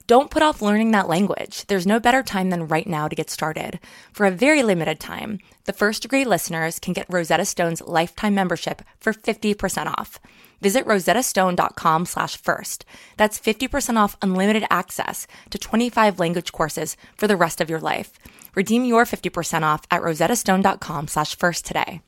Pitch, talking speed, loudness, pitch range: 195 Hz, 175 wpm, -21 LUFS, 165-220 Hz